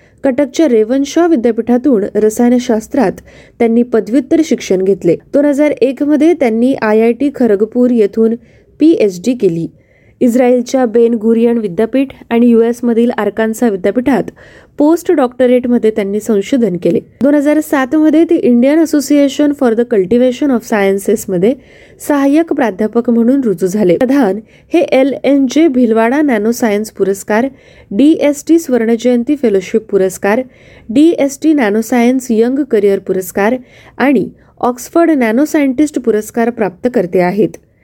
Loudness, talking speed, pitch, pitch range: -12 LUFS, 130 wpm, 240 Hz, 220-280 Hz